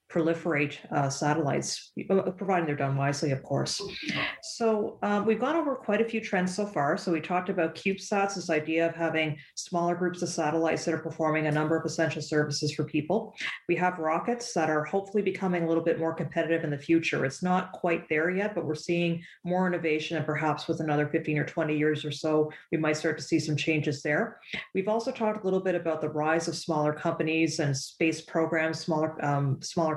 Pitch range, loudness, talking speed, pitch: 155-180 Hz, -29 LUFS, 210 wpm, 165 Hz